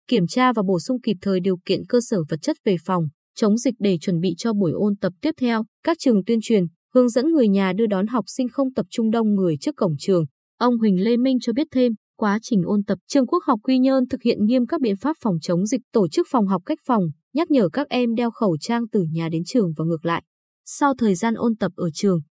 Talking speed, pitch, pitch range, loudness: 265 wpm, 220 Hz, 190-255 Hz, -21 LUFS